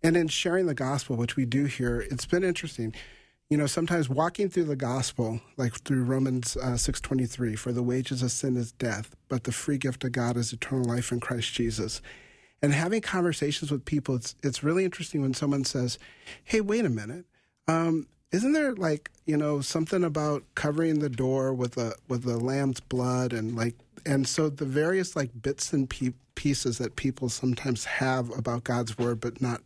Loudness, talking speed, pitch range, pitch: -29 LUFS, 200 wpm, 120-150 Hz, 130 Hz